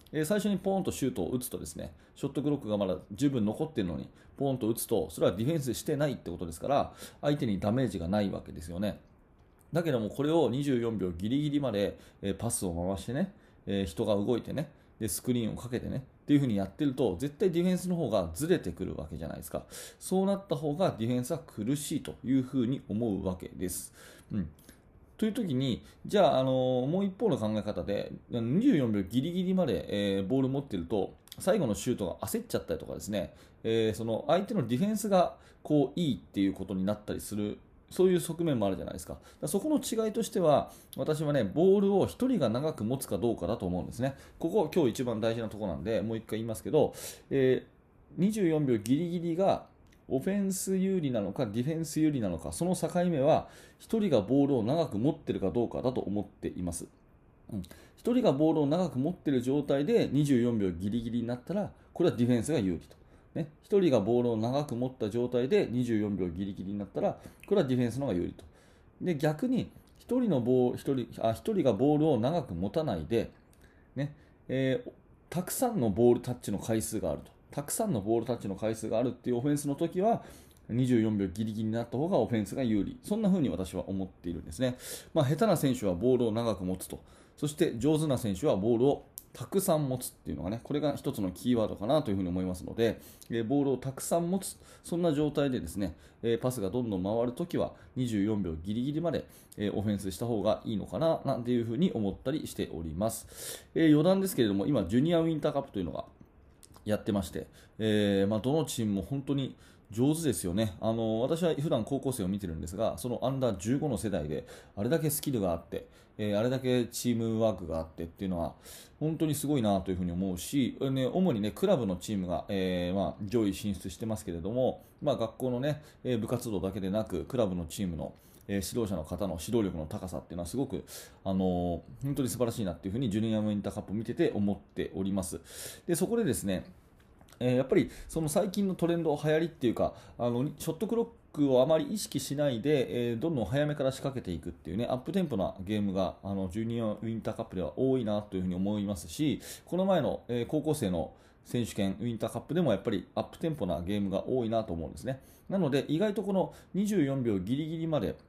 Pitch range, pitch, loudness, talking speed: 100-150 Hz, 120 Hz, -31 LUFS, 435 characters per minute